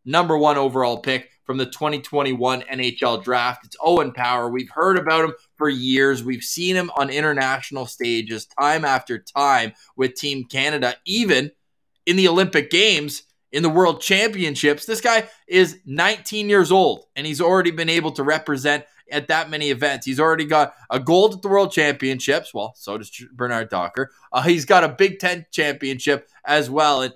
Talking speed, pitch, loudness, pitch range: 175 wpm, 145 Hz, -19 LUFS, 130-170 Hz